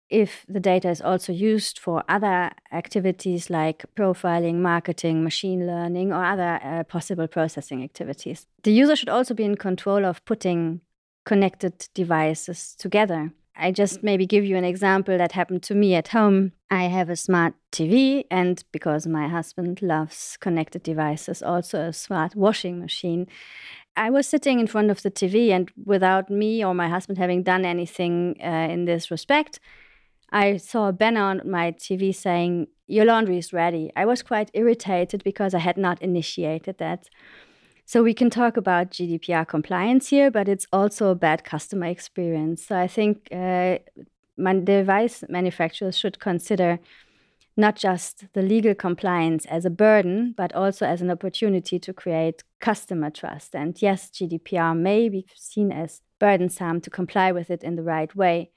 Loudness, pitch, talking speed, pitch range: -23 LUFS, 180 Hz, 165 wpm, 170-200 Hz